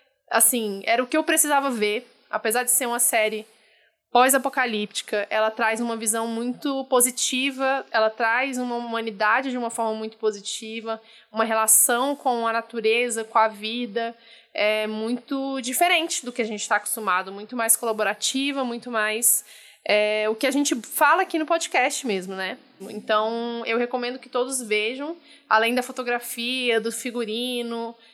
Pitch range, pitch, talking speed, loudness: 220-255 Hz, 230 Hz, 155 wpm, -23 LUFS